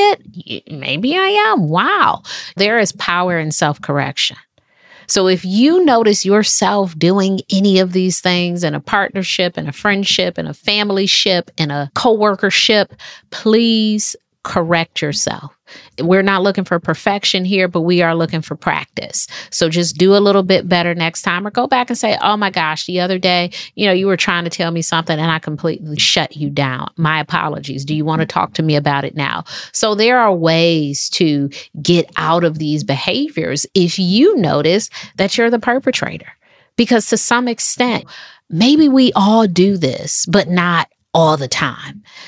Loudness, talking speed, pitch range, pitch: -14 LUFS, 180 wpm, 165-210 Hz, 185 Hz